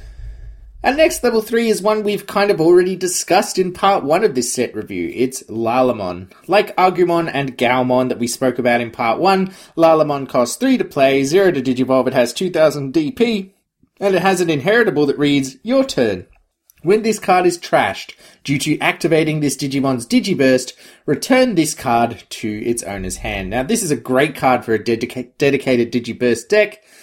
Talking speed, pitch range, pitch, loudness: 180 wpm, 125-195 Hz, 145 Hz, -16 LUFS